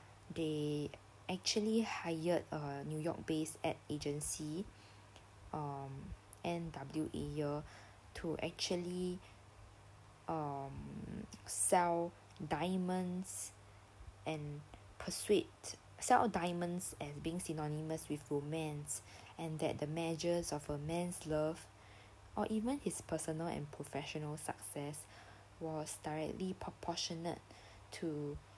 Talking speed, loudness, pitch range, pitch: 90 wpm, -41 LUFS, 105-170 Hz, 150 Hz